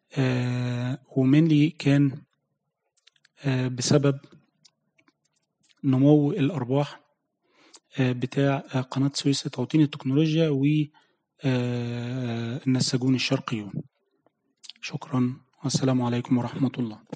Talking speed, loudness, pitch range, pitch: 80 wpm, -25 LUFS, 125-145 Hz, 135 Hz